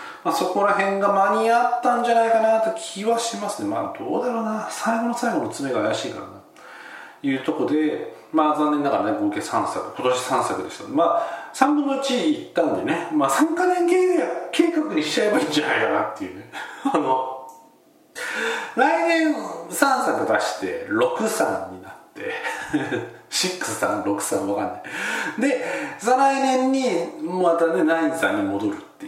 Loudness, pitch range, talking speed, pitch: -22 LUFS, 195-305 Hz, 295 characters per minute, 240 Hz